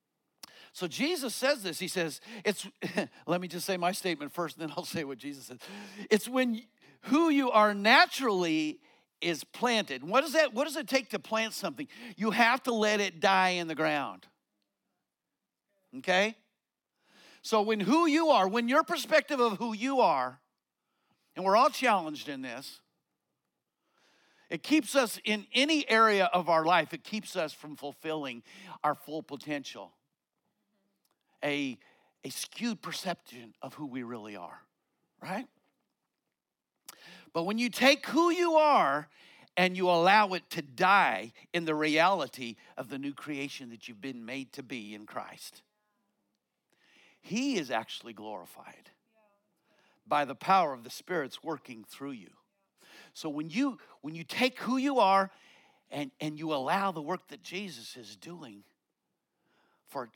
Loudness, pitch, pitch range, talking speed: -29 LUFS, 195 Hz, 155-240 Hz, 155 wpm